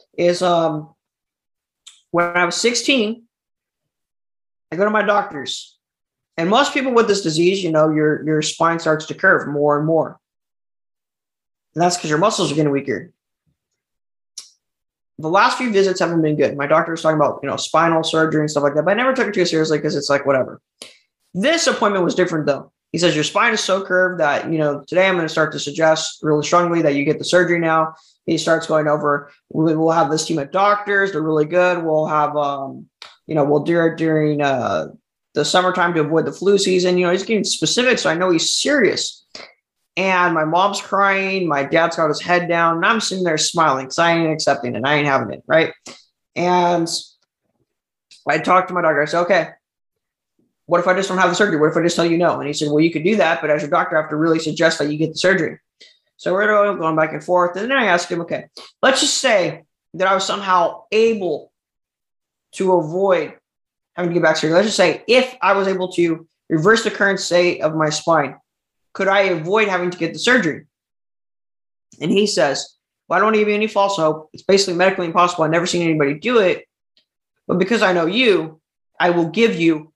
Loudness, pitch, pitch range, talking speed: -17 LUFS, 170 Hz, 155-190 Hz, 220 wpm